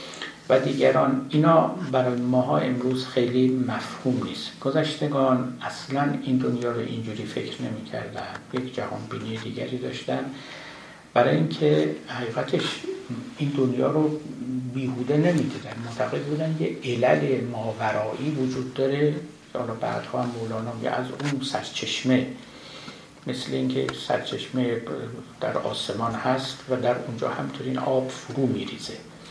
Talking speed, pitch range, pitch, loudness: 125 wpm, 120-135 Hz, 130 Hz, -26 LUFS